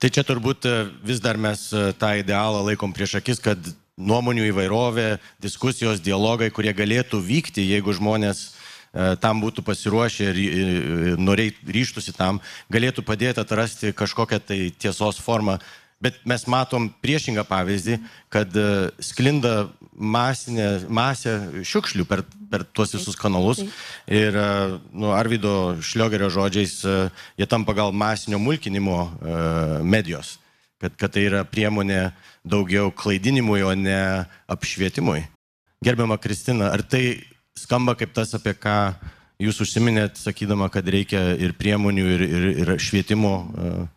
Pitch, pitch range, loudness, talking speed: 105 Hz, 95-115 Hz, -22 LUFS, 125 wpm